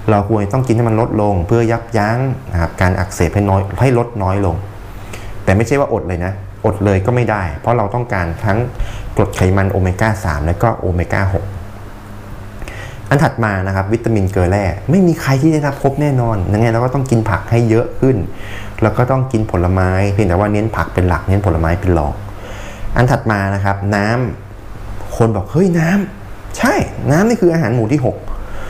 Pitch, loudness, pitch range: 105 Hz, -15 LUFS, 95-115 Hz